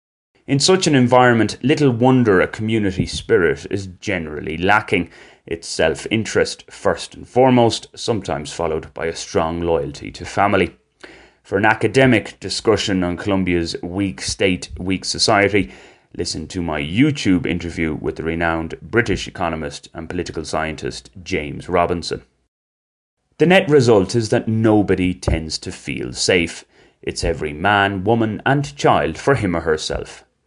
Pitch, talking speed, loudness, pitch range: 95 Hz, 140 wpm, -18 LUFS, 80-110 Hz